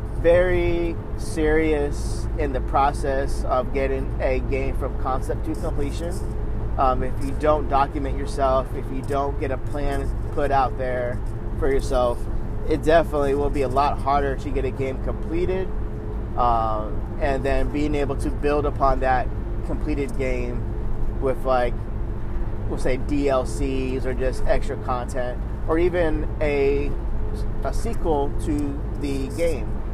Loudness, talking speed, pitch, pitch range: -24 LUFS, 140 wpm, 130 Hz, 110-140 Hz